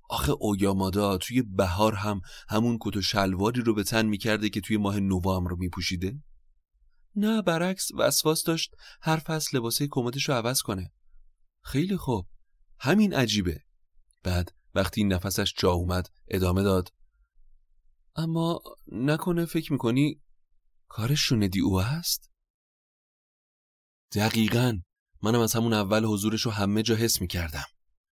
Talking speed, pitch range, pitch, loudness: 130 wpm, 95-135 Hz, 105 Hz, -27 LUFS